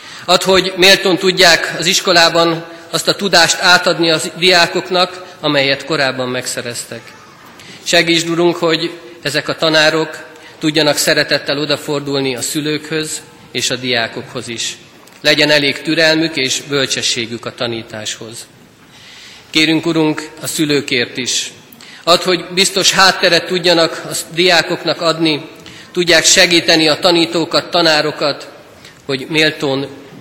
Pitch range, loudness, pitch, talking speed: 145-170 Hz, -13 LUFS, 160 Hz, 115 wpm